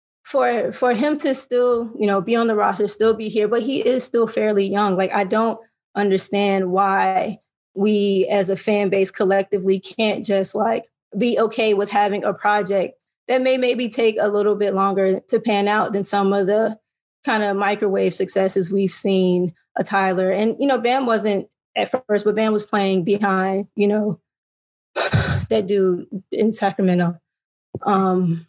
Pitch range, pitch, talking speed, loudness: 195-225 Hz, 205 Hz, 175 wpm, -19 LUFS